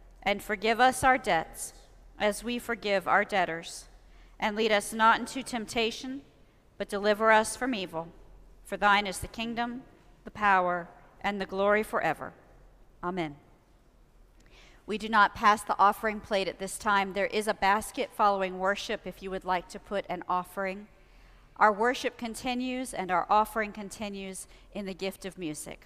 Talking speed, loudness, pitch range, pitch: 160 wpm, -29 LUFS, 185-220 Hz, 205 Hz